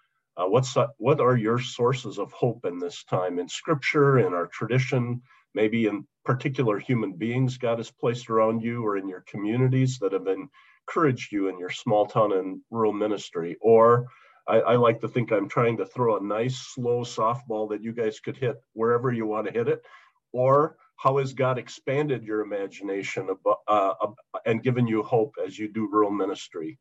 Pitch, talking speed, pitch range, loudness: 115 Hz, 195 wpm, 105-130 Hz, -25 LUFS